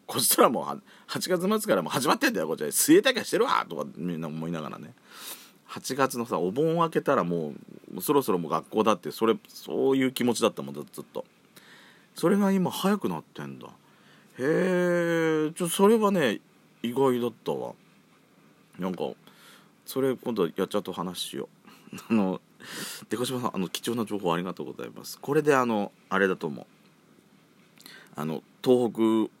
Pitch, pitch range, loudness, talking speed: 130 Hz, 100-170 Hz, -27 LUFS, 350 characters per minute